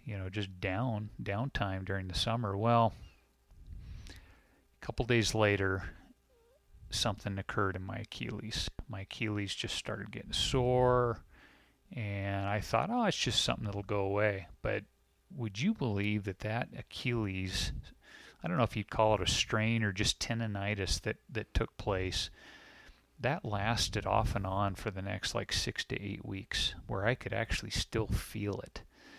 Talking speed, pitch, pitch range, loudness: 160 wpm, 105 Hz, 95-115 Hz, -34 LUFS